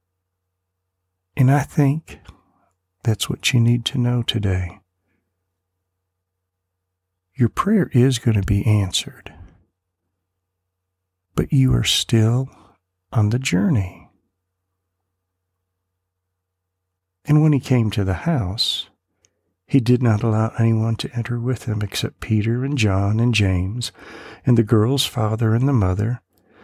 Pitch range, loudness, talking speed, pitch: 95-120 Hz, -20 LUFS, 120 wpm, 100 Hz